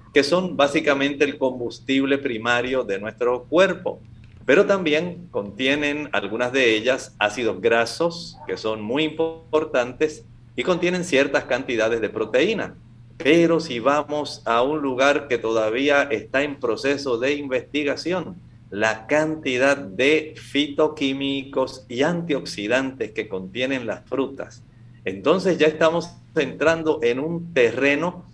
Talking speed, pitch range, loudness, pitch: 120 wpm, 120-155 Hz, -22 LUFS, 140 Hz